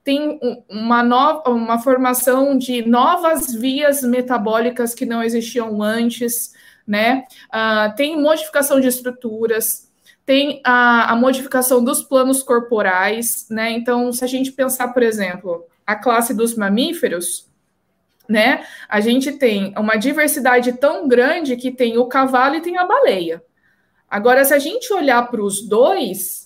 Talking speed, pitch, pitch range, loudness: 140 wpm, 245 Hz, 225-265 Hz, -16 LUFS